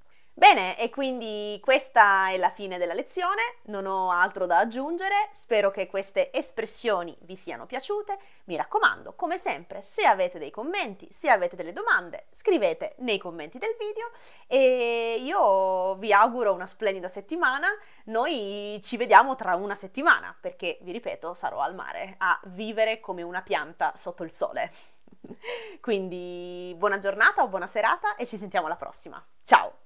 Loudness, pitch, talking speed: -25 LUFS, 225 Hz, 155 wpm